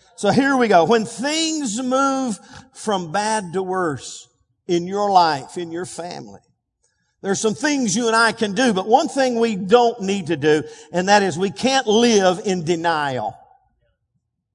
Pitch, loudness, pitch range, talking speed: 210 Hz, -19 LUFS, 180-245 Hz, 170 wpm